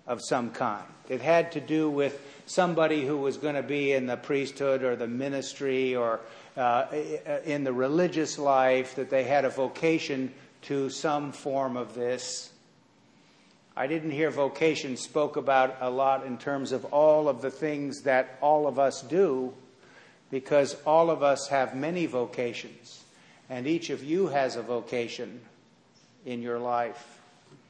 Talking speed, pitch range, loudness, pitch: 160 wpm, 130-150 Hz, -28 LUFS, 135 Hz